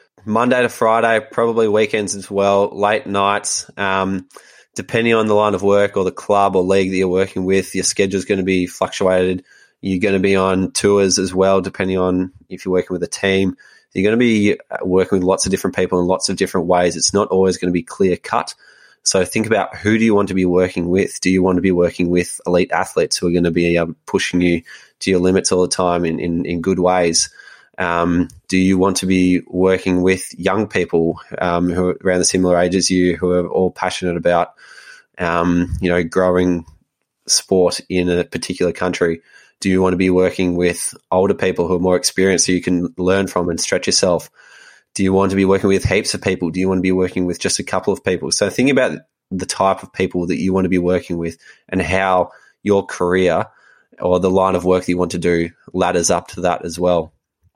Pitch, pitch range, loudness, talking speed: 95 Hz, 90-95 Hz, -17 LUFS, 230 wpm